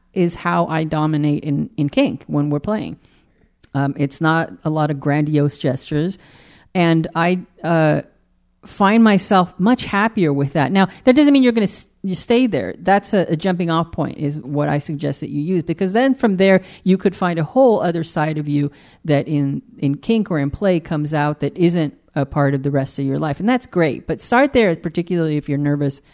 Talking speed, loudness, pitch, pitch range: 215 wpm, -18 LUFS, 165 Hz, 145-190 Hz